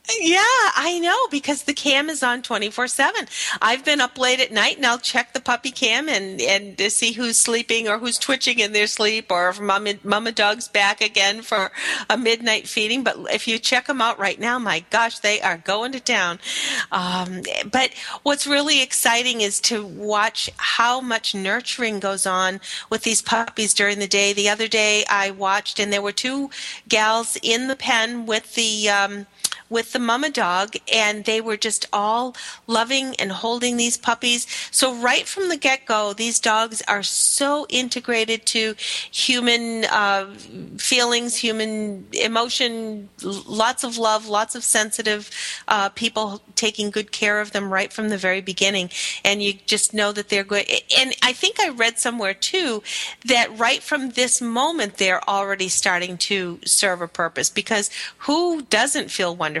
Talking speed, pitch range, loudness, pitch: 175 wpm, 205-245 Hz, -20 LUFS, 225 Hz